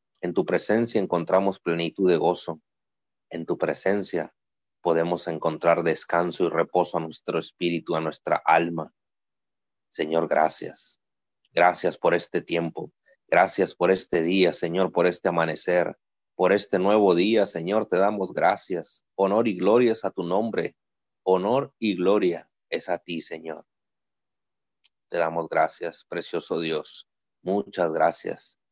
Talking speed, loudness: 135 wpm, -25 LUFS